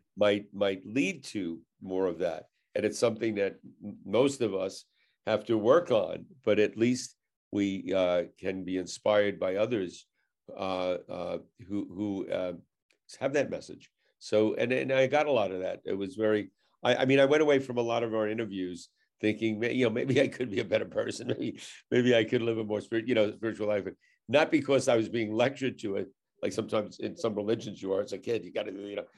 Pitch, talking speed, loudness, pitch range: 105 Hz, 220 wpm, -30 LUFS, 100-115 Hz